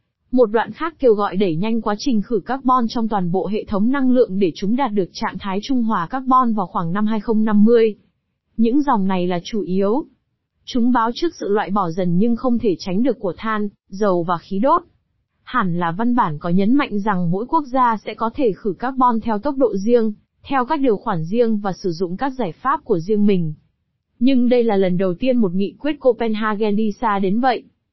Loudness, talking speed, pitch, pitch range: -19 LUFS, 220 wpm, 220 Hz, 195-245 Hz